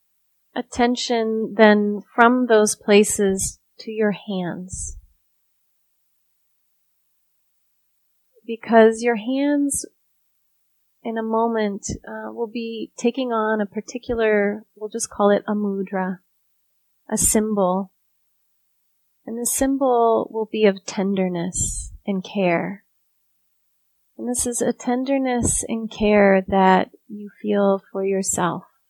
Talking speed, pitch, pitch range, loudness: 105 wpm, 210 Hz, 185-230 Hz, -20 LUFS